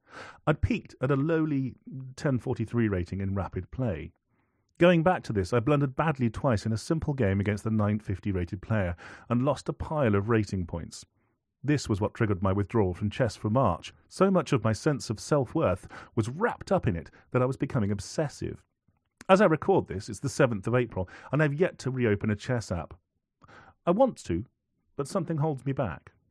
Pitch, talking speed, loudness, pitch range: 115 Hz, 200 wpm, -28 LUFS, 100-140 Hz